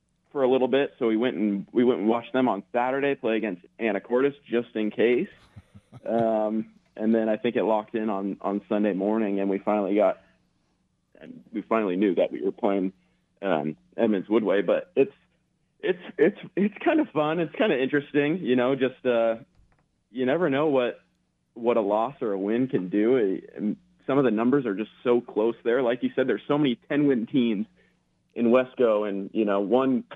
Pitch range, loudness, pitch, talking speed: 105-135 Hz, -25 LUFS, 115 Hz, 200 wpm